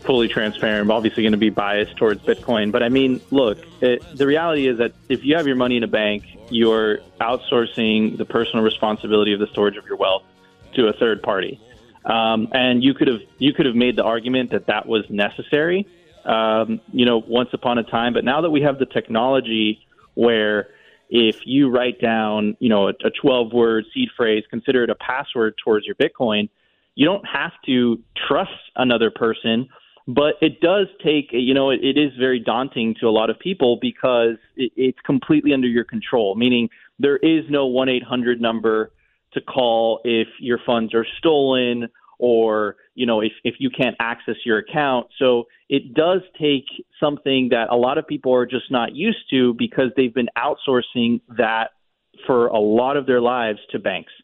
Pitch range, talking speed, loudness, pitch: 110-130 Hz, 190 wpm, -19 LUFS, 120 Hz